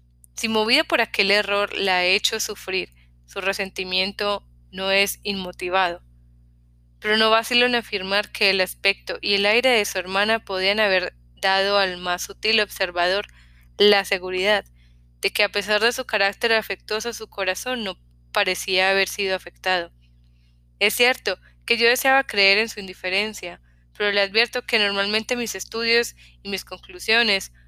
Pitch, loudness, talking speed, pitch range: 195 Hz, -21 LUFS, 155 wpm, 180-215 Hz